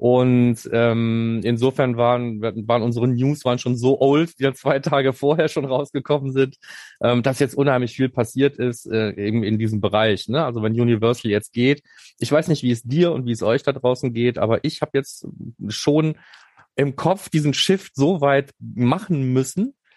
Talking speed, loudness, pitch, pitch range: 190 wpm, -20 LUFS, 130 Hz, 120-140 Hz